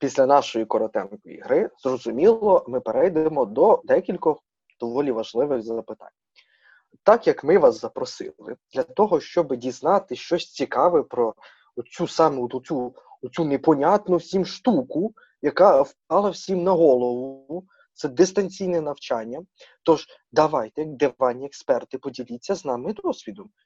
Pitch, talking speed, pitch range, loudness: 160 Hz, 115 wpm, 130-195 Hz, -22 LUFS